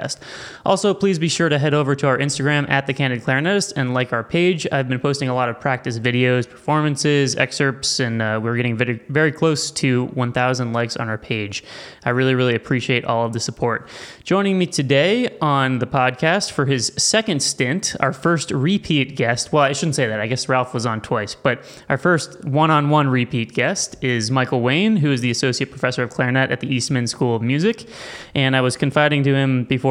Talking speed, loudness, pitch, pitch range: 210 wpm, -19 LUFS, 135 Hz, 125-150 Hz